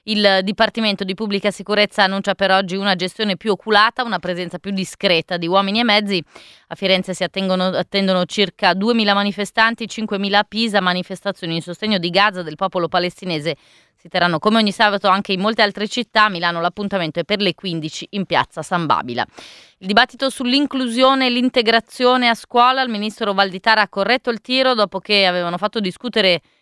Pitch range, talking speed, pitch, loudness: 185-220 Hz, 175 wpm, 200 Hz, -17 LUFS